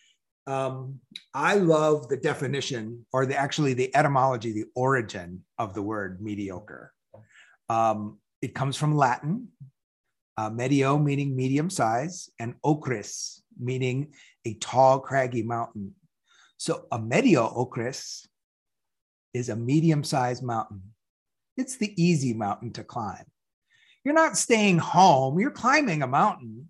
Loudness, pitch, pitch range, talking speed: -25 LUFS, 130 Hz, 115-145 Hz, 125 wpm